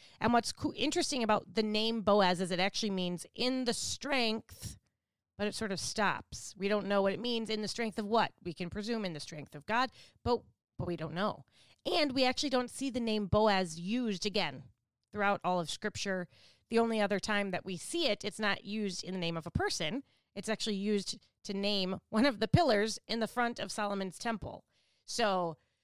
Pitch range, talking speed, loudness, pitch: 185-225 Hz, 210 wpm, -33 LUFS, 210 Hz